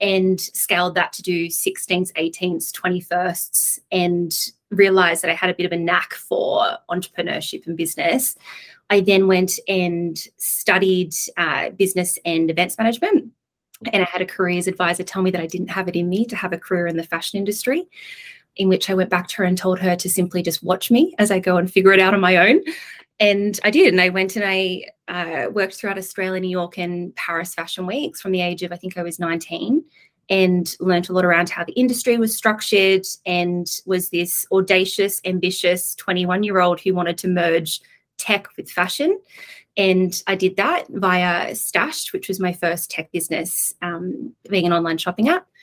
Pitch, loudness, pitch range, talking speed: 185 Hz, -19 LUFS, 175-200 Hz, 195 wpm